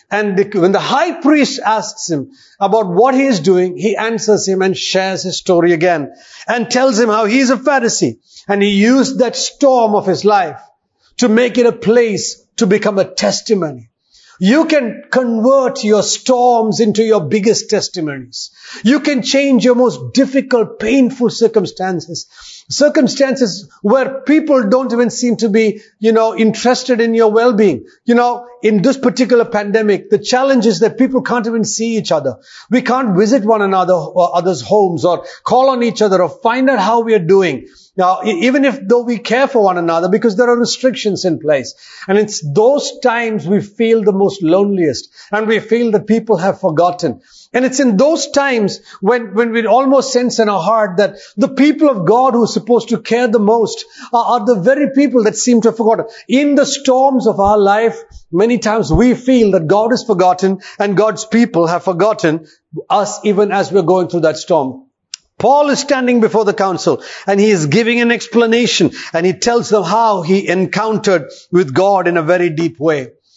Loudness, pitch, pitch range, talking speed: -13 LUFS, 220 Hz, 195-245 Hz, 190 wpm